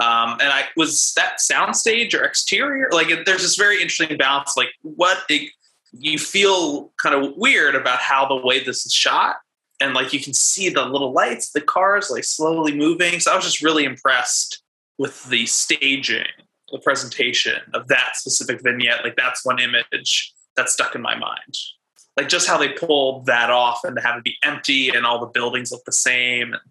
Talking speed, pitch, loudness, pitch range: 195 wpm, 140 Hz, -18 LUFS, 125-160 Hz